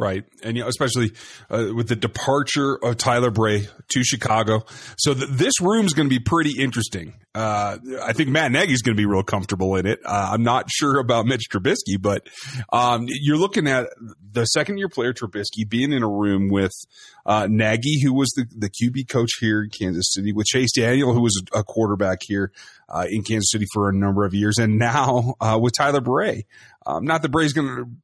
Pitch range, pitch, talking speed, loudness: 105-135 Hz, 115 Hz, 215 wpm, -21 LUFS